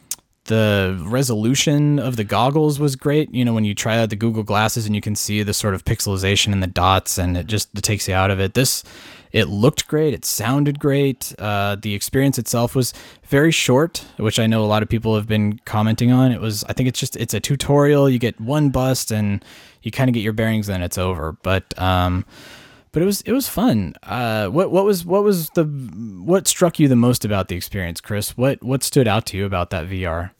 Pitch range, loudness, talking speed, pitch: 100-135 Hz, -19 LUFS, 230 wpm, 115 Hz